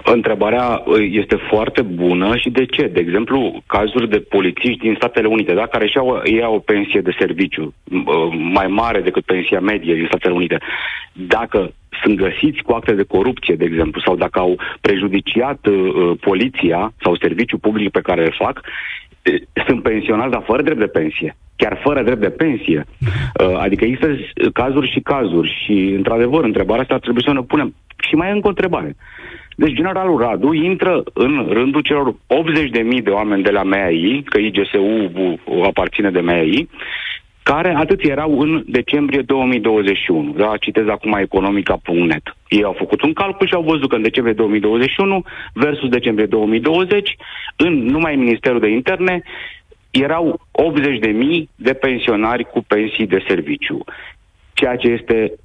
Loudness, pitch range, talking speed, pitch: -16 LUFS, 100-150 Hz, 160 wpm, 115 Hz